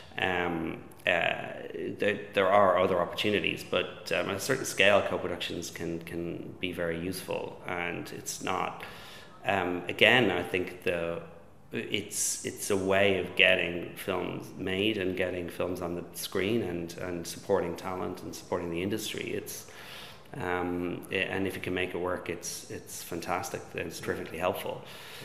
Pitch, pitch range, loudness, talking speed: 90 Hz, 85-95 Hz, -30 LUFS, 155 wpm